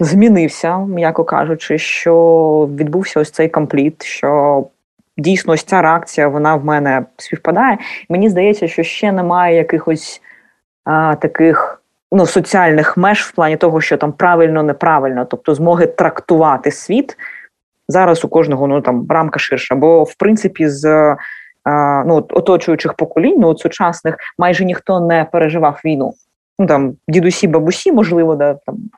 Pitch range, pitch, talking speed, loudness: 150-175 Hz, 160 Hz, 145 wpm, -13 LUFS